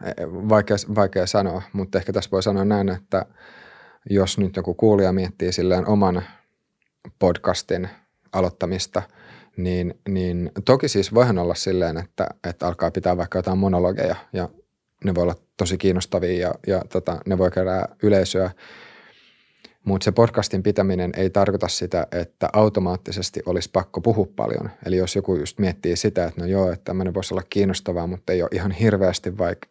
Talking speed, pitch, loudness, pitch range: 160 wpm, 95 Hz, -22 LUFS, 90-100 Hz